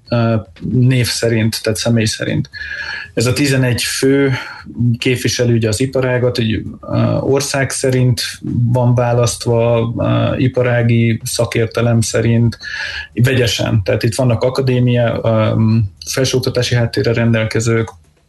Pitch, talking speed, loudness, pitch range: 120 Hz, 90 wpm, -15 LUFS, 115-125 Hz